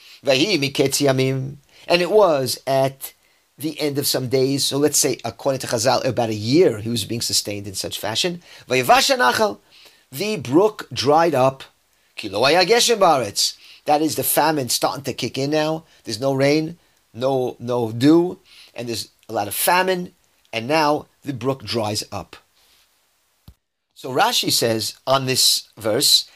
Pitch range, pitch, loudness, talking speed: 120-155 Hz, 135 Hz, -19 LUFS, 140 wpm